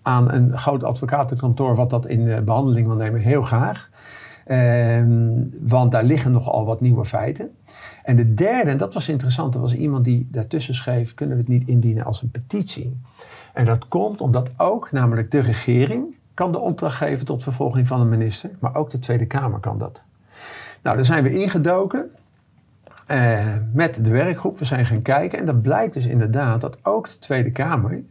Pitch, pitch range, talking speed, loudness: 125 Hz, 120-140 Hz, 190 wpm, -20 LUFS